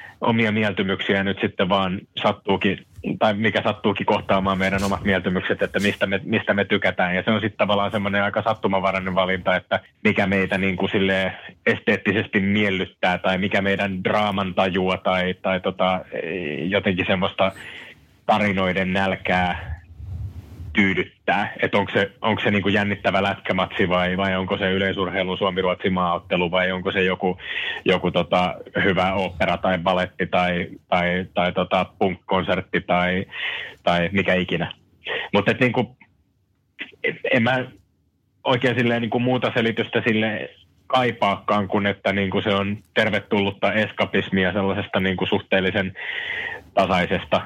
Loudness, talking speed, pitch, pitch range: -22 LUFS, 135 wpm, 95 Hz, 95-105 Hz